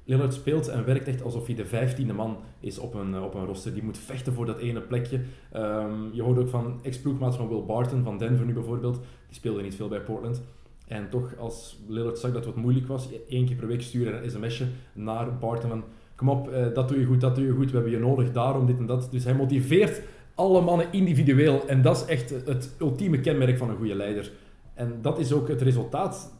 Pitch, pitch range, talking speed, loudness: 125 Hz, 115-135 Hz, 235 wpm, -27 LUFS